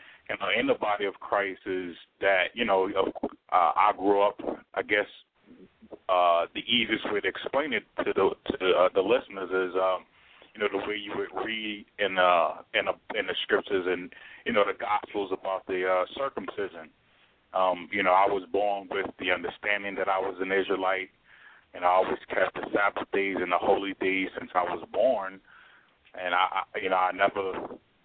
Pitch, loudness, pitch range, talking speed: 95 Hz, -27 LUFS, 95-100 Hz, 195 wpm